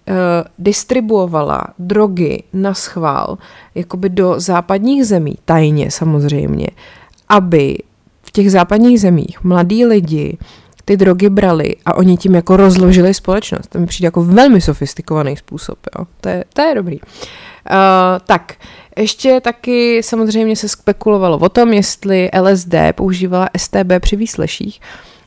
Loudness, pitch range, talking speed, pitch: -12 LUFS, 175-210 Hz, 130 wpm, 190 Hz